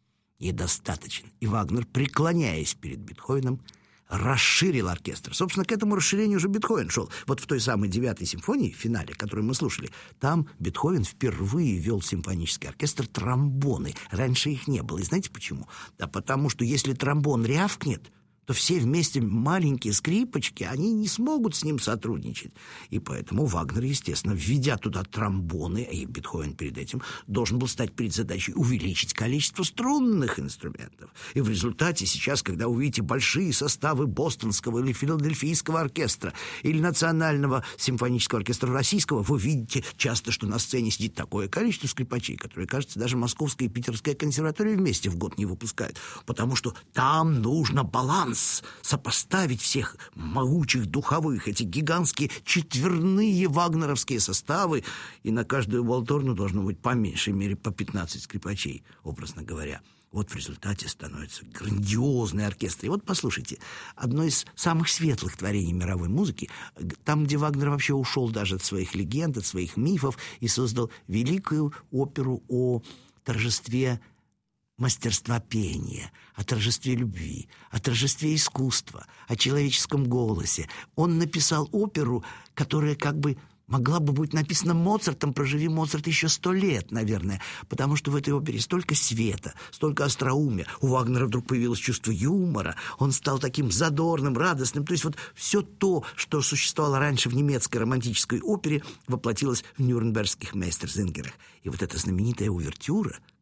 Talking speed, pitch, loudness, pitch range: 145 wpm, 125 Hz, -26 LUFS, 110-150 Hz